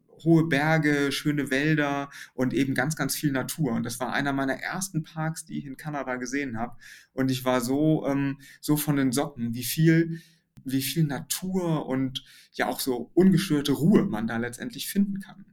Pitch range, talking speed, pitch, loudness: 130-160 Hz, 185 wpm, 140 Hz, -26 LUFS